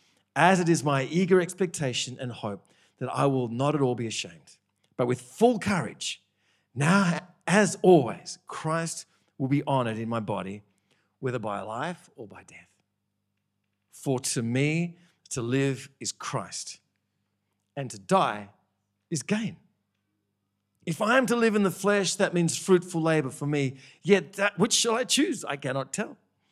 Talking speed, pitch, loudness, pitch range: 160 wpm, 140 Hz, -26 LUFS, 110-180 Hz